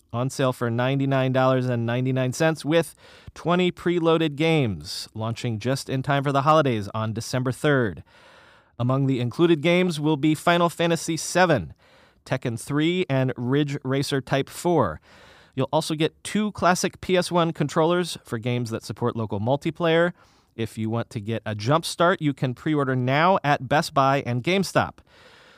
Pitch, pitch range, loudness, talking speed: 140 Hz, 125-165 Hz, -23 LUFS, 165 wpm